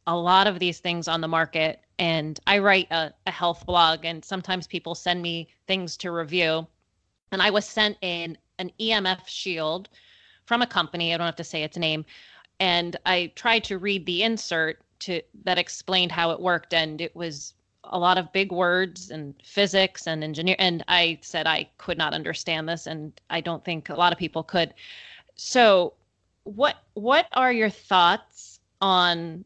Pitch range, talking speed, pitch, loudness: 165-190 Hz, 185 wpm, 175 Hz, -24 LUFS